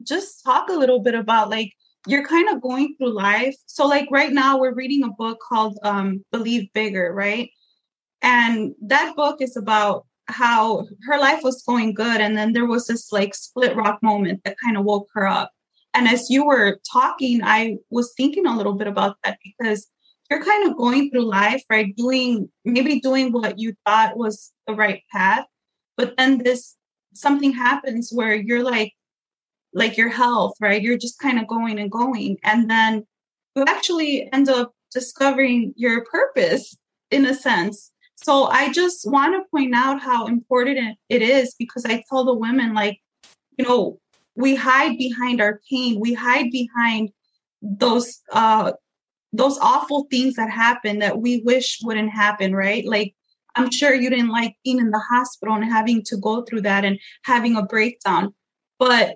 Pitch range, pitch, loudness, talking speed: 220-260 Hz, 240 Hz, -19 LUFS, 180 wpm